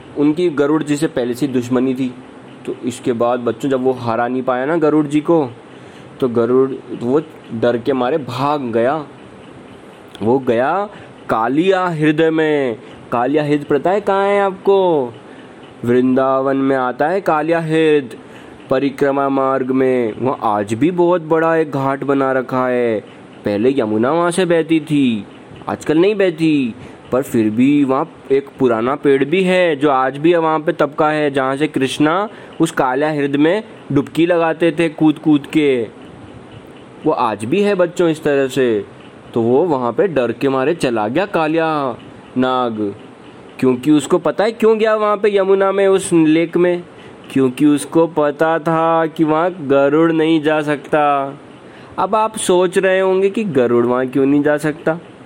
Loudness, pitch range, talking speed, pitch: -16 LUFS, 130-165 Hz, 165 wpm, 150 Hz